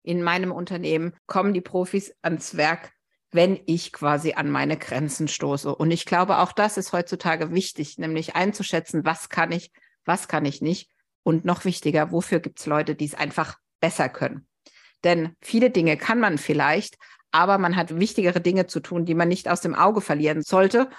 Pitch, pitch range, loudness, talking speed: 170 Hz, 155-180 Hz, -23 LUFS, 185 wpm